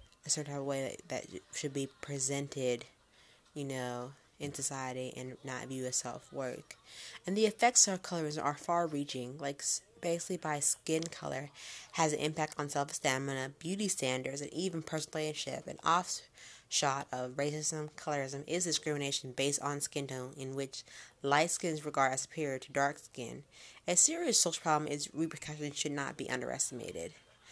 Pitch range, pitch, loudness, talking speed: 135-155 Hz, 145 Hz, -35 LUFS, 160 wpm